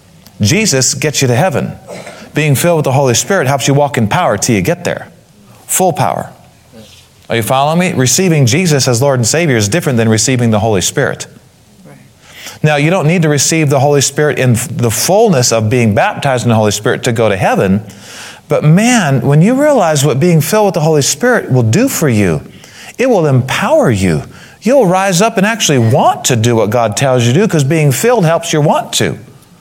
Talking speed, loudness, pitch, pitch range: 210 wpm, -11 LUFS, 140 Hz, 120-165 Hz